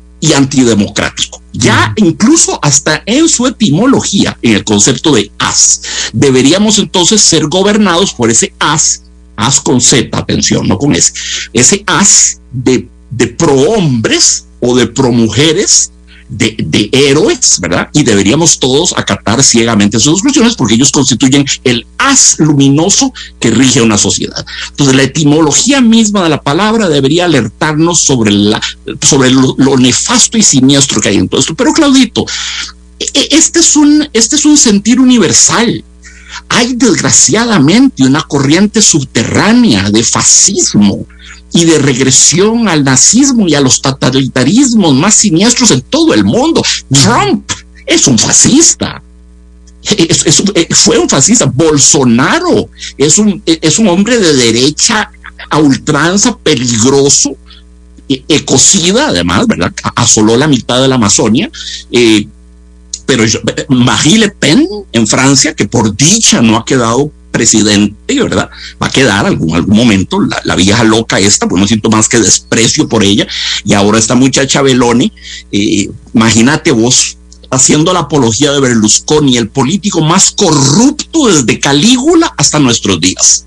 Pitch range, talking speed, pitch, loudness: 110-180 Hz, 140 wpm, 135 Hz, -7 LUFS